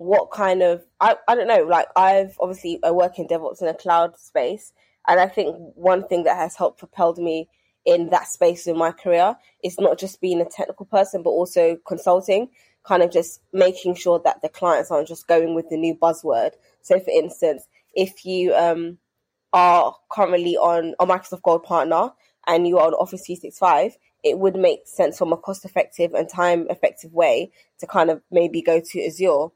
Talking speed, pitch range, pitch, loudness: 195 wpm, 170-190 Hz, 180 Hz, -20 LUFS